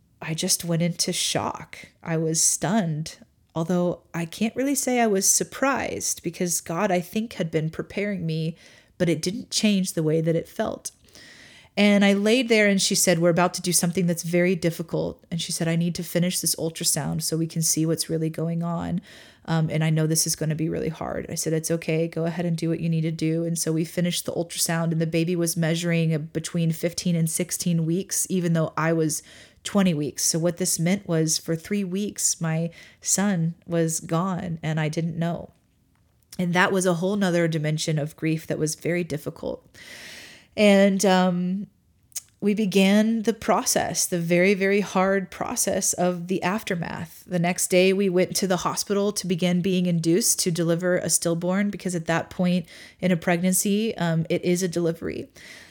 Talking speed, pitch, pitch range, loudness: 195 wpm, 175 Hz, 165-190 Hz, -23 LUFS